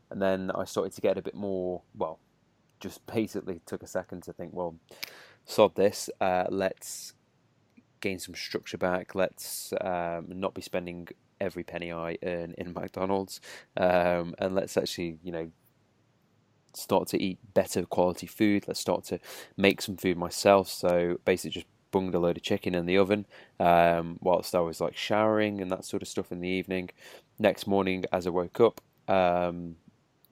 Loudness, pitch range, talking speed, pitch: -29 LUFS, 85-95 Hz, 175 wpm, 90 Hz